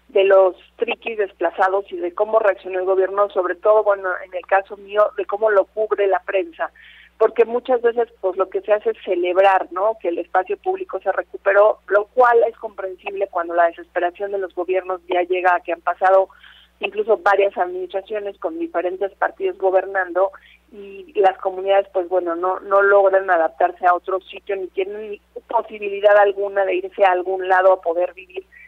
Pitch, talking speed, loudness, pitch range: 195 Hz, 185 wpm, -19 LUFS, 185-205 Hz